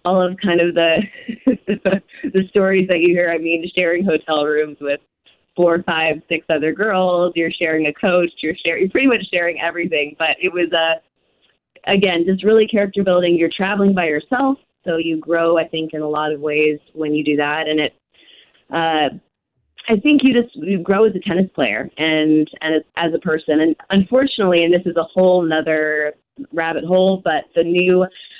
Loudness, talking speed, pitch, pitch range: -17 LUFS, 195 wpm, 170 Hz, 160-190 Hz